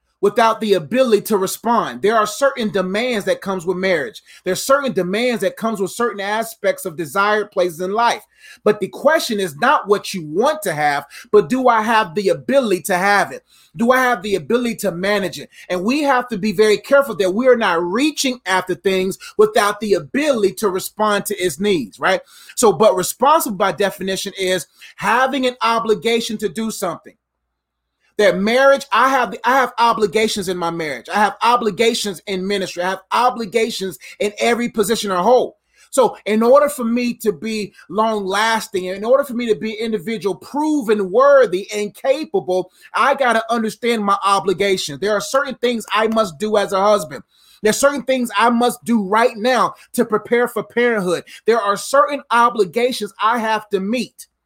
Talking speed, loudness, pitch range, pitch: 185 wpm, -17 LUFS, 195-240 Hz, 215 Hz